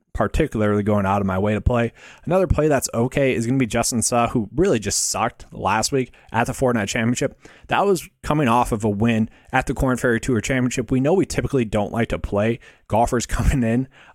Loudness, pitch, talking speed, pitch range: -21 LUFS, 120 Hz, 220 wpm, 110-130 Hz